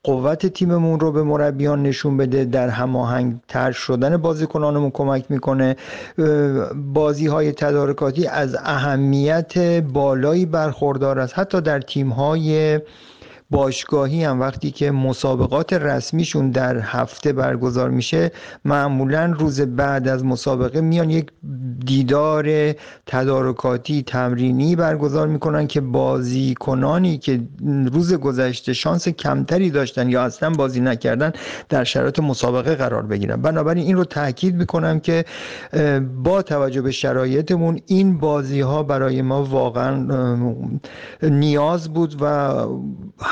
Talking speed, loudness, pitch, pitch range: 115 wpm, -19 LUFS, 145 Hz, 130-155 Hz